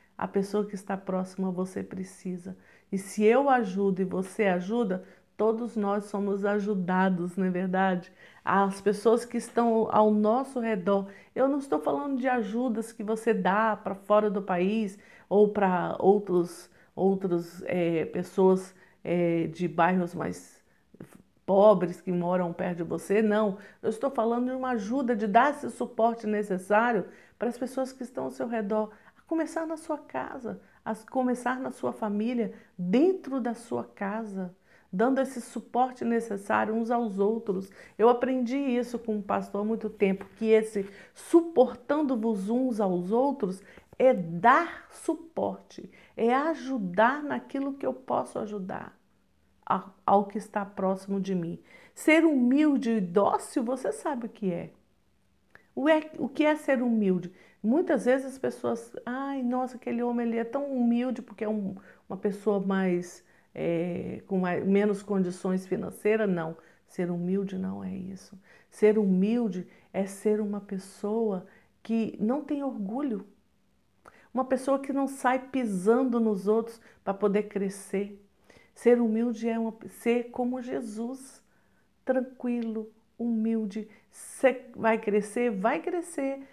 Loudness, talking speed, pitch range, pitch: -28 LUFS, 145 wpm, 195-245 Hz, 215 Hz